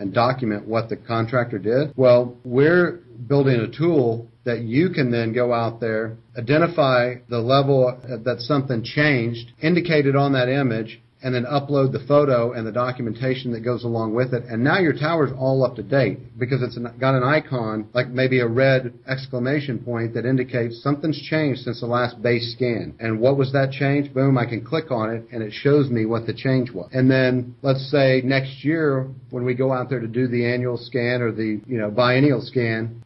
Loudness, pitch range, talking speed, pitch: -21 LUFS, 115-135 Hz, 200 wpm, 125 Hz